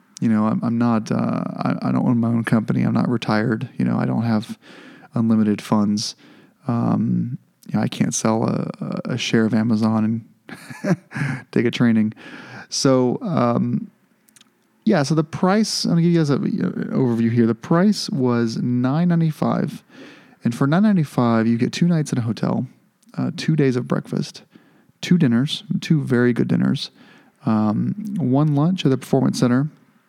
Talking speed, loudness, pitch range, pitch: 170 wpm, -20 LUFS, 115-170 Hz, 125 Hz